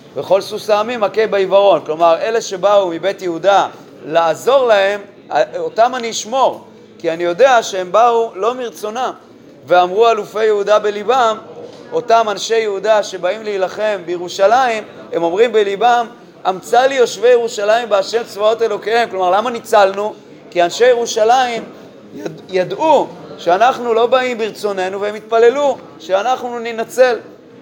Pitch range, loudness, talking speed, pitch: 195-235 Hz, -15 LUFS, 125 wpm, 215 Hz